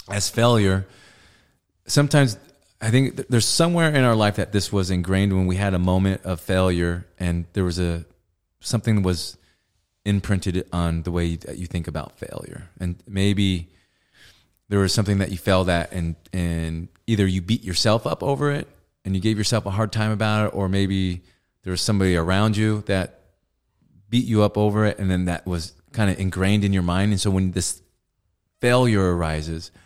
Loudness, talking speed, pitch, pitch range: -22 LUFS, 185 wpm, 95 Hz, 90-105 Hz